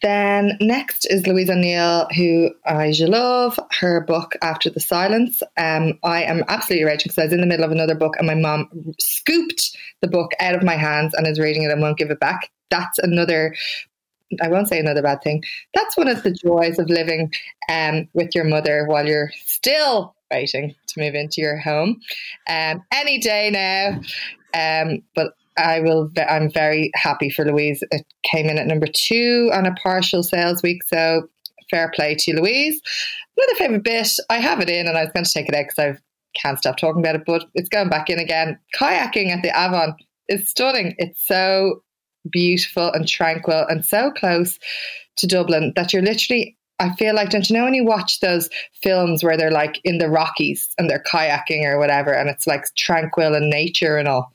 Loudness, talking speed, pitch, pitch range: -19 LUFS, 200 wpm, 170 Hz, 155-195 Hz